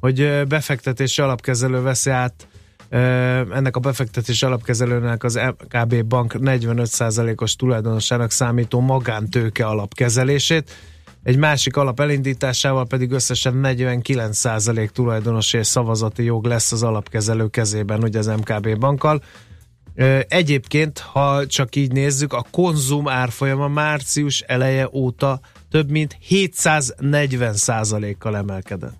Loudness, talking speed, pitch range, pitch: -19 LUFS, 105 wpm, 115-135 Hz, 125 Hz